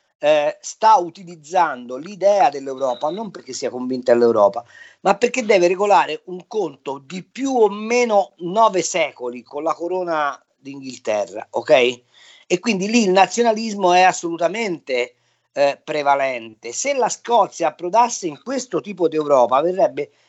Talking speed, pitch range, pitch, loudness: 135 wpm, 140-220 Hz, 180 Hz, -19 LUFS